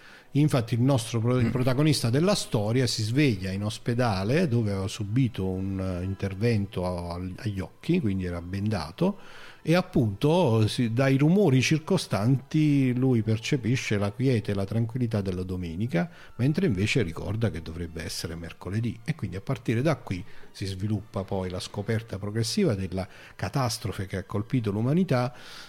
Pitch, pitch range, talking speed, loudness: 115 Hz, 95-130 Hz, 140 wpm, -27 LUFS